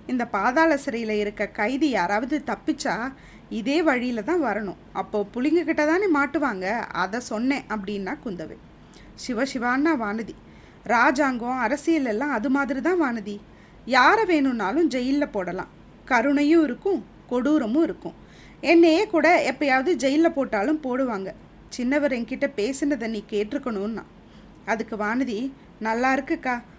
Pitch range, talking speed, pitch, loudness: 220-300 Hz, 115 wpm, 260 Hz, -23 LUFS